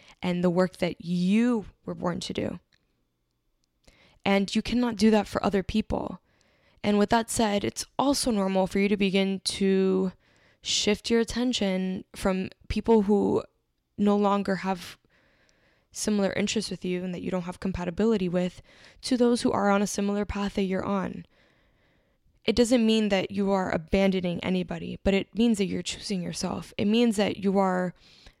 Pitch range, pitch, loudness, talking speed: 185-215 Hz, 195 Hz, -26 LUFS, 170 wpm